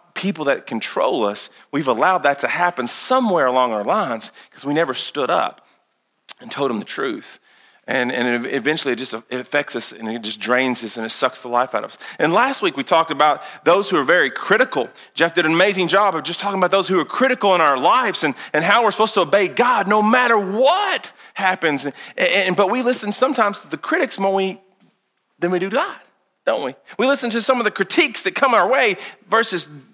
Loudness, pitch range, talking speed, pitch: -18 LUFS, 130-210 Hz, 225 wpm, 180 Hz